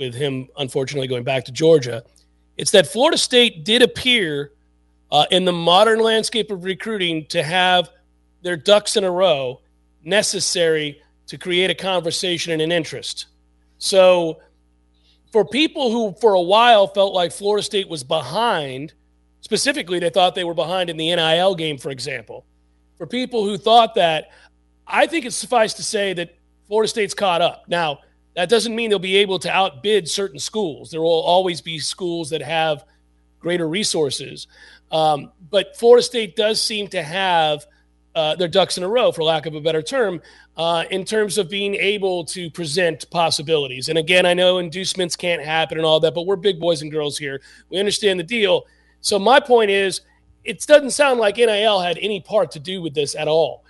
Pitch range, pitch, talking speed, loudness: 155-205 Hz, 175 Hz, 185 wpm, -18 LUFS